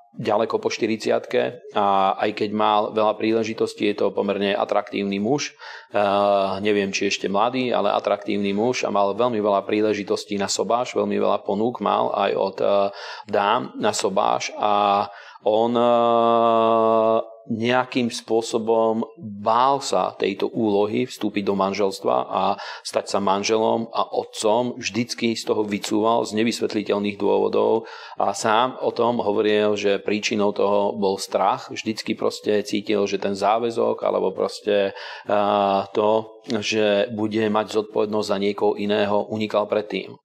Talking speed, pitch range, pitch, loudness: 135 wpm, 100-115 Hz, 105 Hz, -22 LUFS